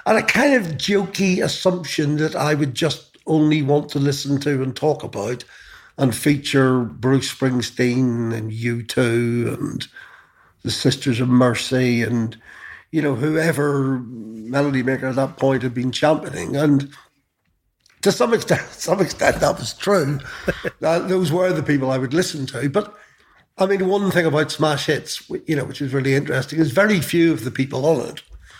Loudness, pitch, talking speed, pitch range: -20 LUFS, 140 Hz, 170 wpm, 130-155 Hz